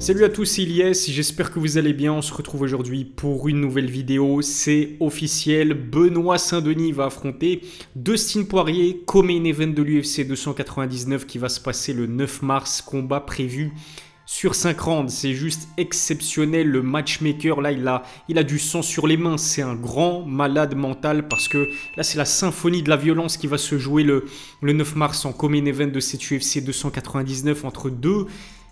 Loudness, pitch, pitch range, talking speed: -21 LUFS, 150 Hz, 140-165 Hz, 185 wpm